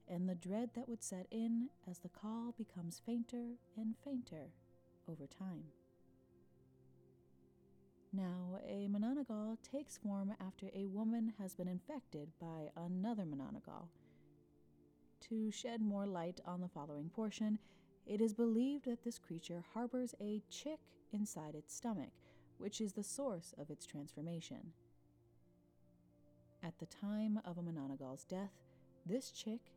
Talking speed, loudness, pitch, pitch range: 135 wpm, -45 LUFS, 185 Hz, 145-220 Hz